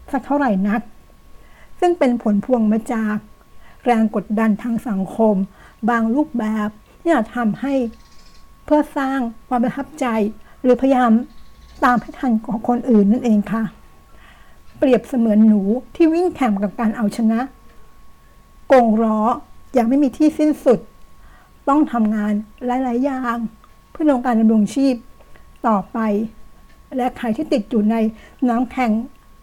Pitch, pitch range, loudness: 235 Hz, 220-265 Hz, -18 LUFS